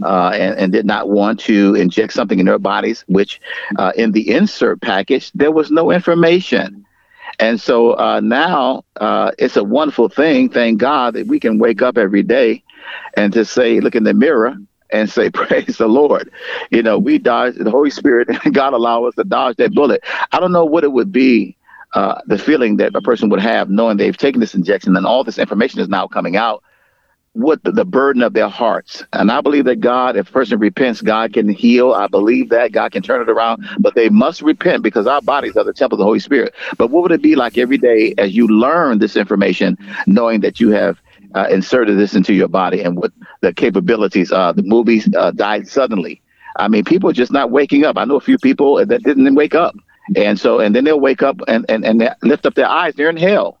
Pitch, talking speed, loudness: 140 Hz, 225 wpm, -13 LUFS